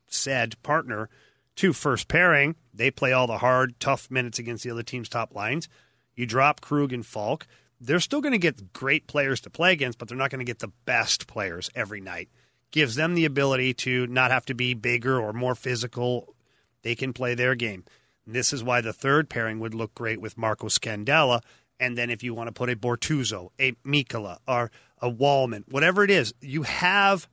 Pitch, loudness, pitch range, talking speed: 125 Hz, -25 LUFS, 120-140 Hz, 205 wpm